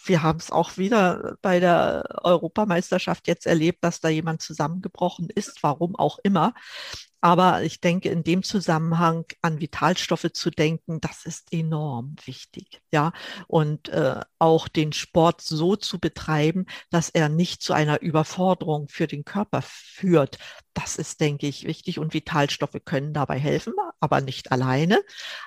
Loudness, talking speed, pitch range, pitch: -24 LUFS, 150 wpm, 155-180 Hz, 165 Hz